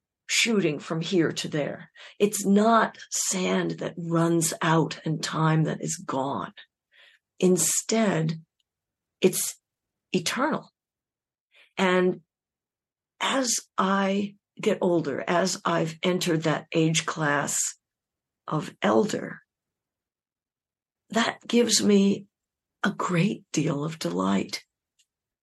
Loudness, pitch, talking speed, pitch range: -25 LUFS, 175 Hz, 95 wpm, 160-195 Hz